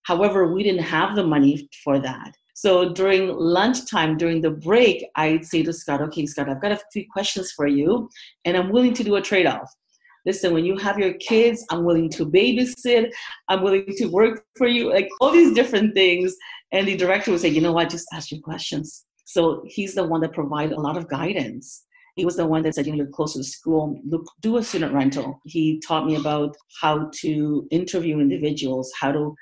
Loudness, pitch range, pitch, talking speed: -21 LUFS, 155-195 Hz, 170 Hz, 210 wpm